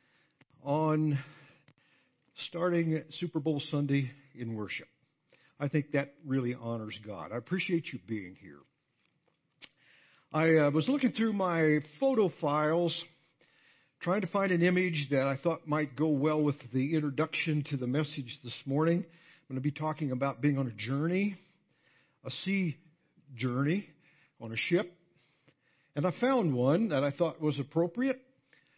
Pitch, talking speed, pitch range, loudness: 150 Hz, 145 wpm, 140-170 Hz, -32 LUFS